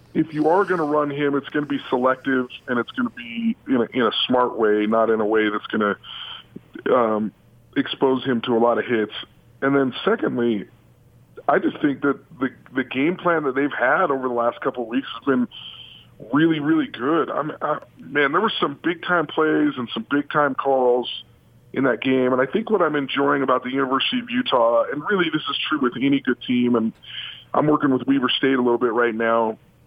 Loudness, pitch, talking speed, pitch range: -21 LUFS, 135 Hz, 220 wpm, 120-150 Hz